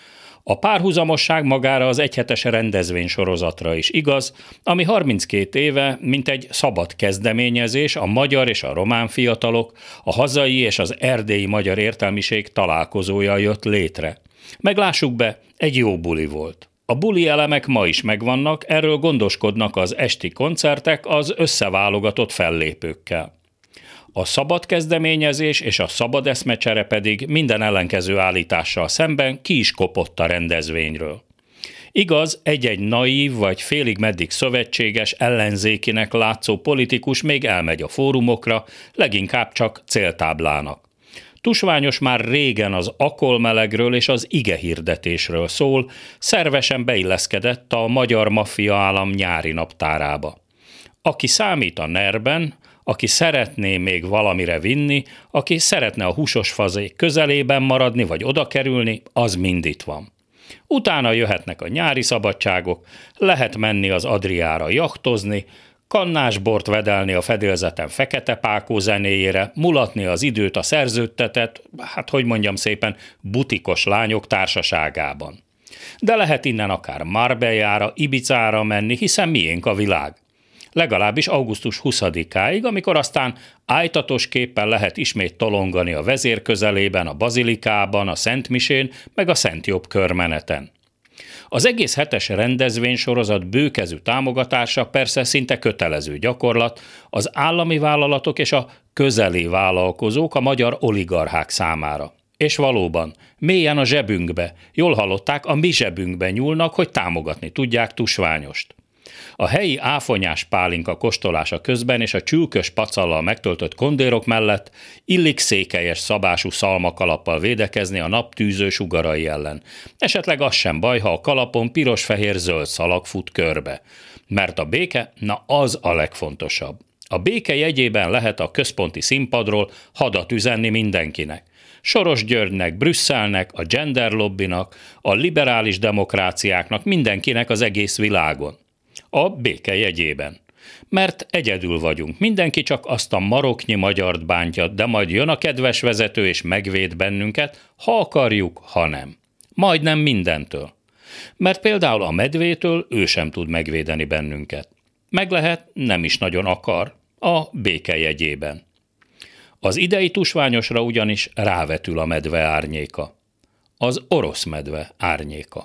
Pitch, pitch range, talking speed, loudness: 110 Hz, 95-135 Hz, 125 wpm, -19 LUFS